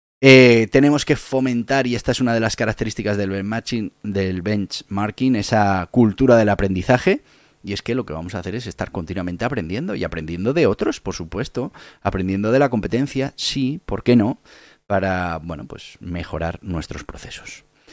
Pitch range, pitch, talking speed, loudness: 95-125 Hz, 110 Hz, 170 wpm, -19 LUFS